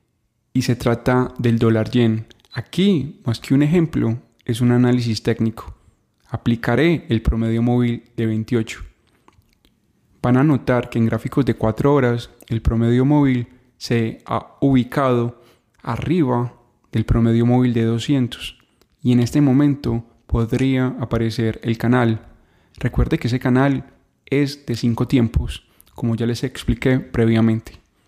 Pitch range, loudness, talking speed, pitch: 115-125 Hz, -19 LUFS, 135 wpm, 120 Hz